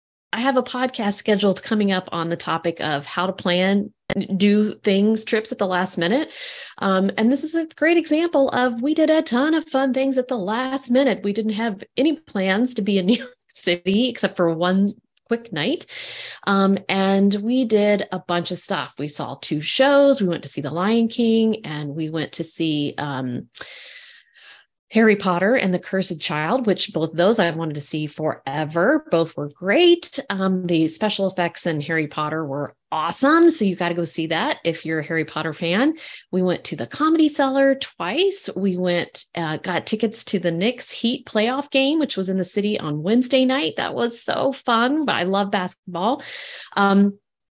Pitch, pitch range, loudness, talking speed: 200 Hz, 175-255 Hz, -21 LUFS, 195 wpm